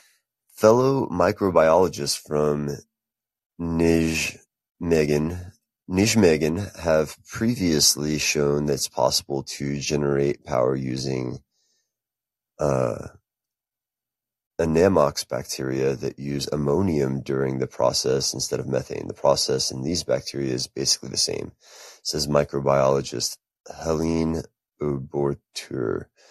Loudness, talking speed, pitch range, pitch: -23 LUFS, 95 wpm, 70-90 Hz, 75 Hz